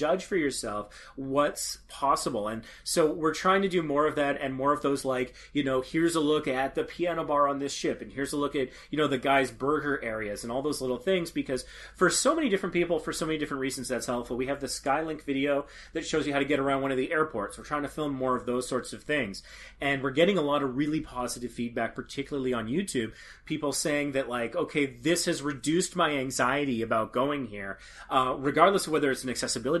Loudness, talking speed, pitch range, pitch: -29 LUFS, 240 wpm, 130-155 Hz, 140 Hz